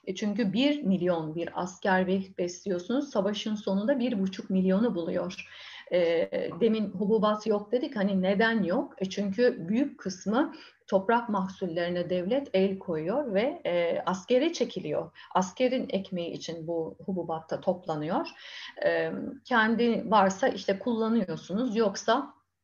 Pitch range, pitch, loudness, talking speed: 185-245 Hz, 200 Hz, -29 LUFS, 110 wpm